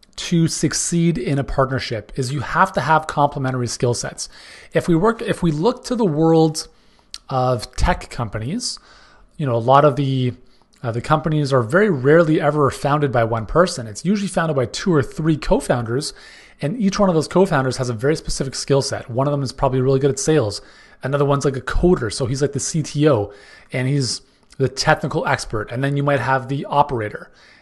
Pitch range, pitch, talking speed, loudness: 130-165 Hz, 145 Hz, 200 wpm, -19 LUFS